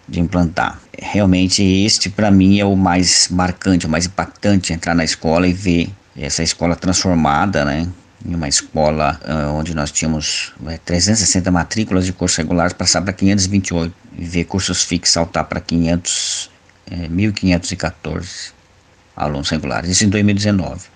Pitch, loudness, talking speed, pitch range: 90 Hz, -16 LUFS, 140 wpm, 80-95 Hz